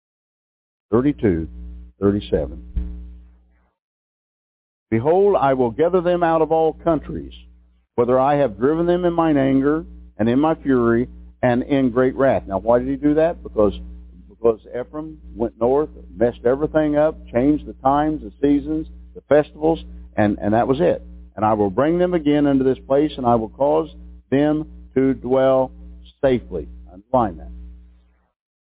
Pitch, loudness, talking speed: 120 Hz, -19 LUFS, 150 wpm